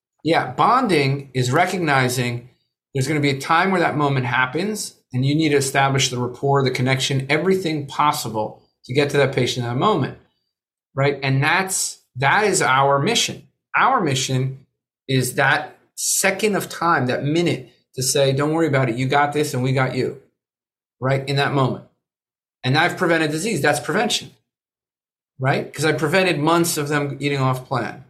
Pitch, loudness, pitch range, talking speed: 140 Hz, -19 LUFS, 130-155 Hz, 175 wpm